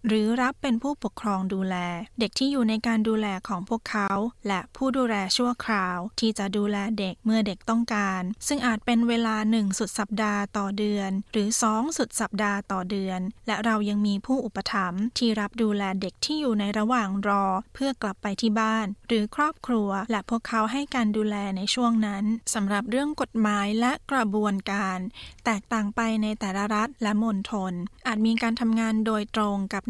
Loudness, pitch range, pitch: -26 LUFS, 200-230 Hz, 215 Hz